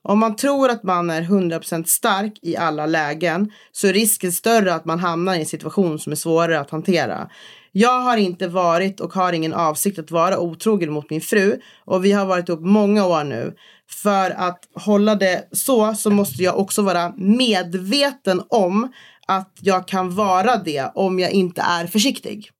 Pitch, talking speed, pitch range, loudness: 185 Hz, 185 wpm, 170-210 Hz, -19 LUFS